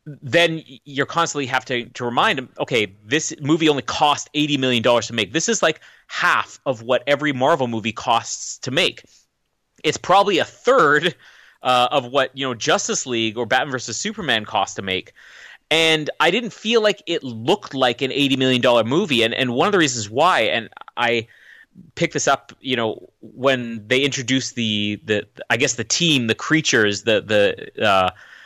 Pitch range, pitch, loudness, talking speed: 120-155 Hz, 135 Hz, -19 LUFS, 190 wpm